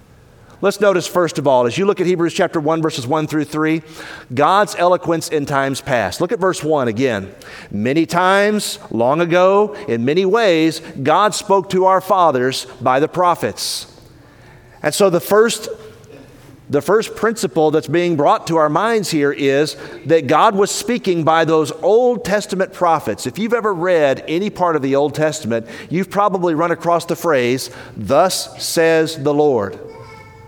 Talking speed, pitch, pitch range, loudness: 165 wpm, 160 Hz, 140-190 Hz, -16 LUFS